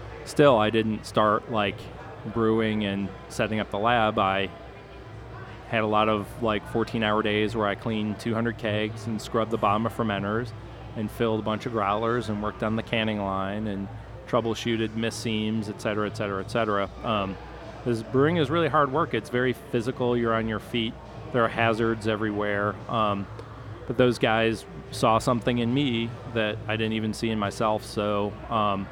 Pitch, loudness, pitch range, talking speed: 110 Hz, -26 LUFS, 105-115 Hz, 175 wpm